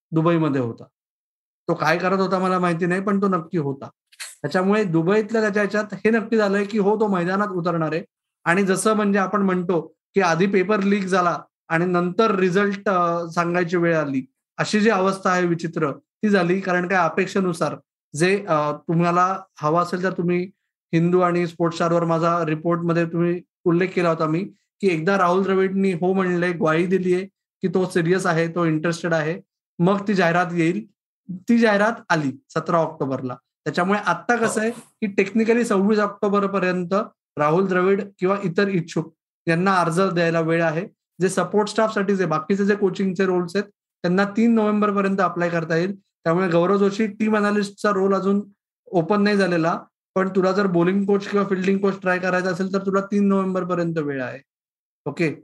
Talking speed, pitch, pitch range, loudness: 170 wpm, 185 Hz, 170-200 Hz, -21 LUFS